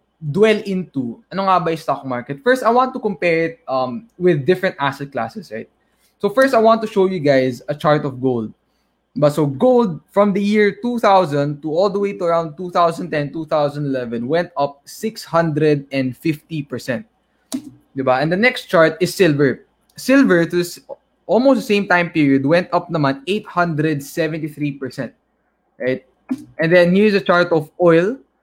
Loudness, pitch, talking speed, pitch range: -17 LUFS, 170 Hz, 160 wpm, 145-200 Hz